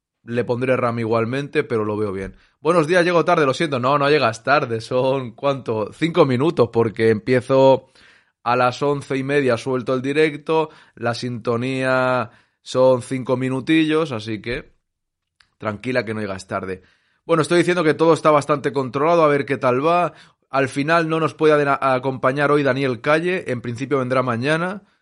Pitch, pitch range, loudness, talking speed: 135 Hz, 120-155 Hz, -19 LUFS, 170 wpm